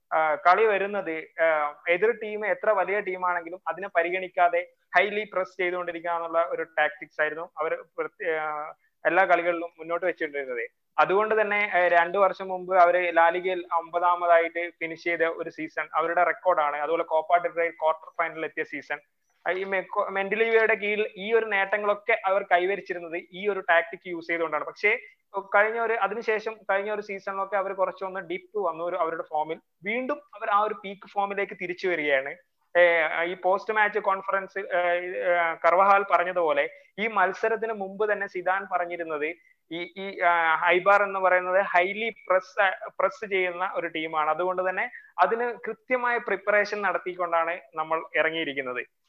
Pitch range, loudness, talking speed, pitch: 170-205 Hz, -25 LUFS, 130 wpm, 180 Hz